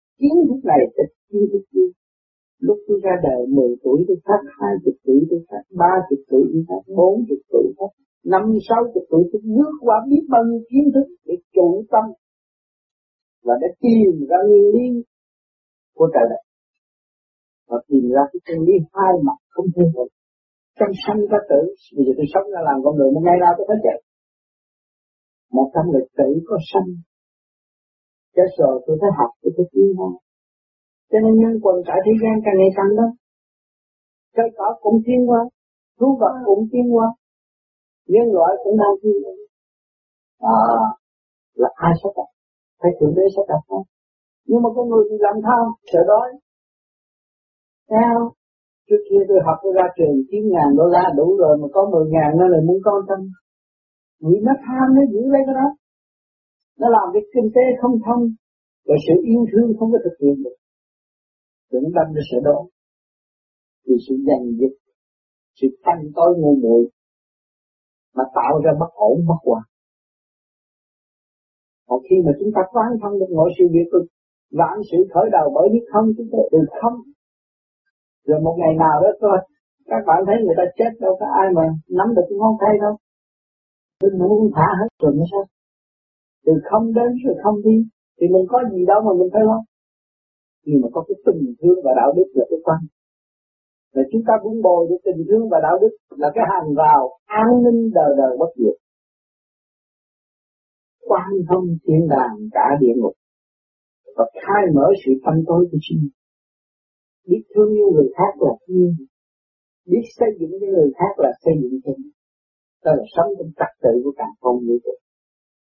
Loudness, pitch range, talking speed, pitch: -17 LUFS, 160-230 Hz, 180 wpm, 190 Hz